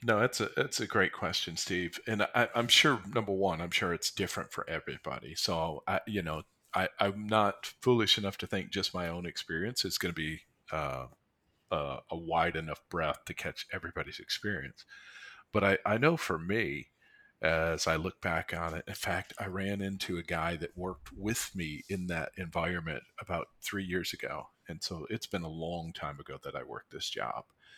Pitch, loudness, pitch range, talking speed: 90 Hz, -33 LUFS, 80-105 Hz, 200 wpm